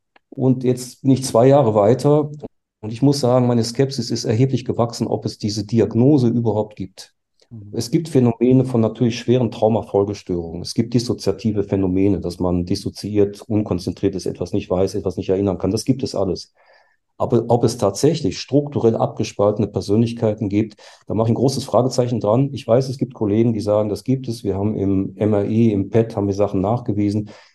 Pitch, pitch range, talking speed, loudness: 110 Hz, 100-125 Hz, 185 wpm, -19 LUFS